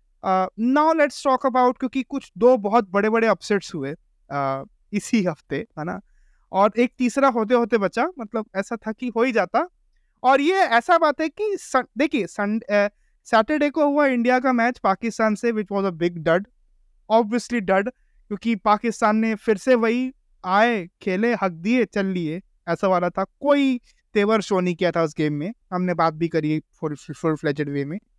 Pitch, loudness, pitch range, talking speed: 220 Hz, -22 LUFS, 185-250 Hz, 170 wpm